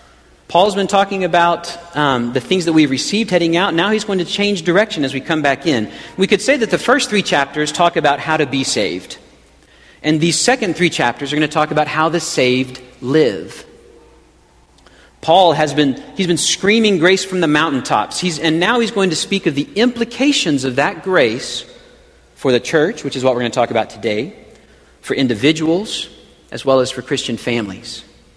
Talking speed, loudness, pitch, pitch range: 200 wpm, -15 LUFS, 160 Hz, 135-190 Hz